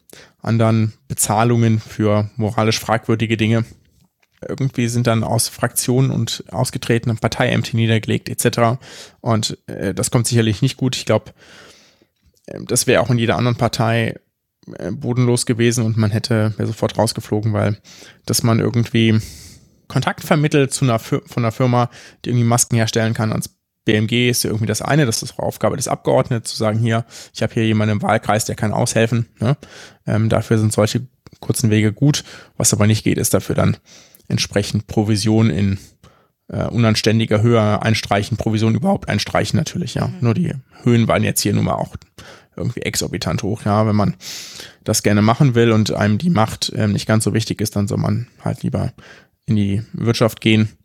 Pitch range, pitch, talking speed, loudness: 110-120 Hz, 115 Hz, 175 wpm, -18 LUFS